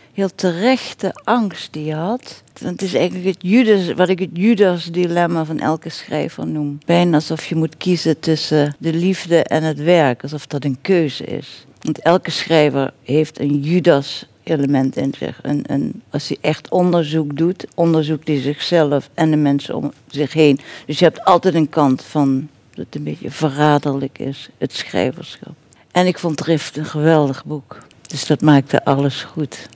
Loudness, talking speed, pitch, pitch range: -17 LUFS, 175 wpm, 155 Hz, 145-175 Hz